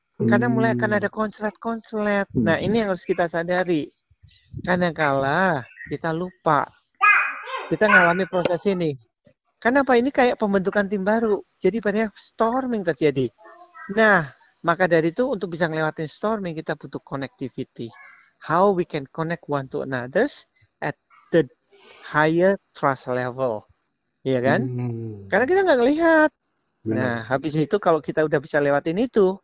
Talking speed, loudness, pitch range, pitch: 135 wpm, -22 LUFS, 140-215 Hz, 175 Hz